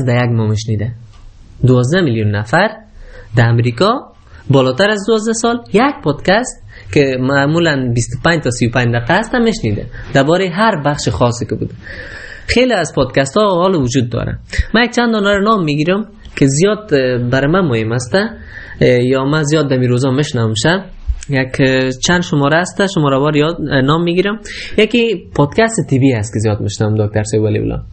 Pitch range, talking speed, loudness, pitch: 120-185 Hz, 155 wpm, -14 LUFS, 140 Hz